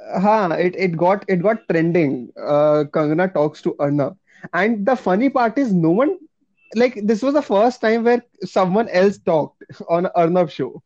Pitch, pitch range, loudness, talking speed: 185 Hz, 170-225 Hz, -18 LUFS, 175 wpm